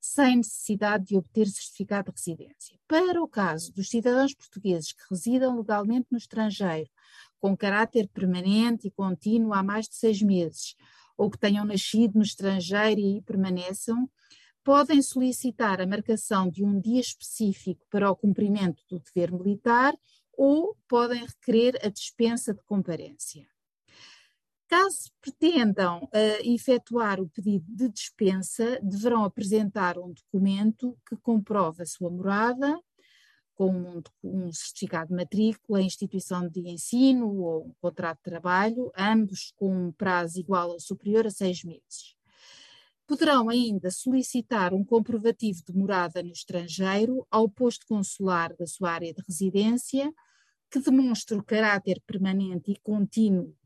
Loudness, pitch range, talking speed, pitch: -27 LUFS, 185-235 Hz, 135 wpm, 205 Hz